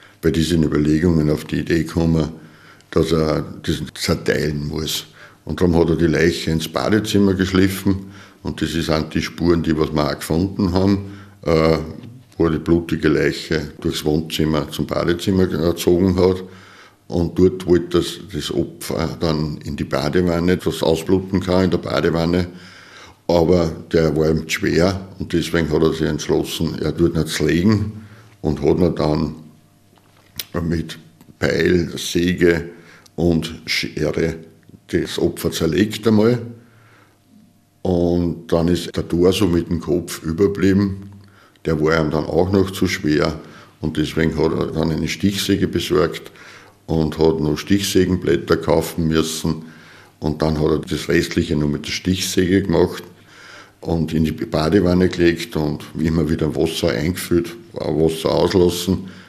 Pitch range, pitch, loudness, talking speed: 80-95 Hz, 85 Hz, -19 LUFS, 145 wpm